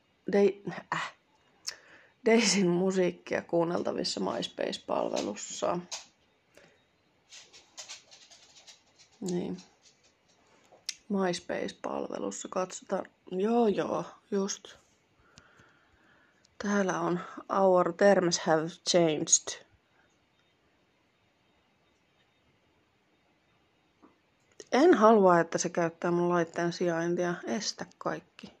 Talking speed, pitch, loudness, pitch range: 60 wpm, 180 Hz, -29 LUFS, 175-200 Hz